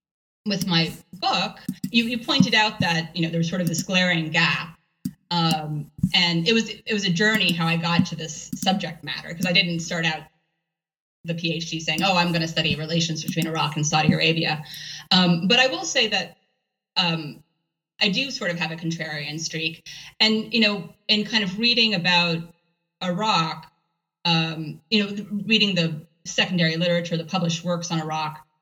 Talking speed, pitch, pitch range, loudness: 180 wpm, 170 Hz, 160-195 Hz, -22 LUFS